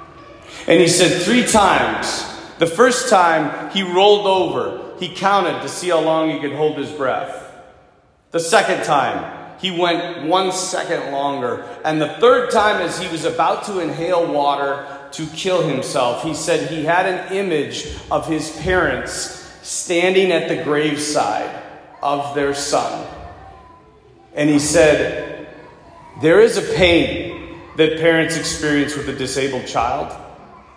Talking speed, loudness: 145 wpm, -17 LUFS